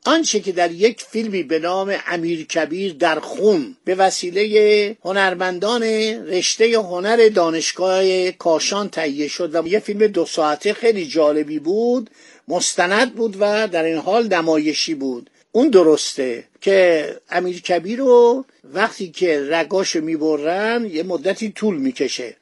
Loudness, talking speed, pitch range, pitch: -18 LUFS, 130 wpm, 165-220 Hz, 190 Hz